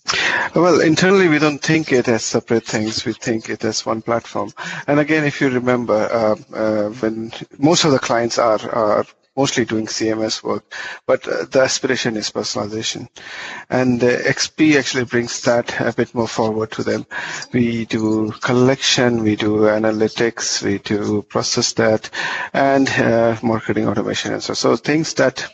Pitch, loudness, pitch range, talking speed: 120 Hz, -18 LUFS, 110-135 Hz, 165 wpm